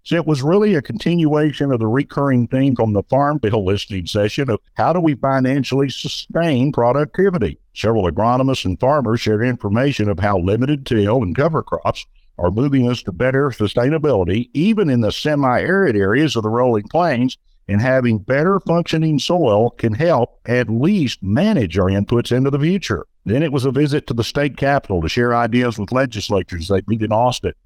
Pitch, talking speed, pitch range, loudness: 125 Hz, 185 wpm, 110-145 Hz, -17 LUFS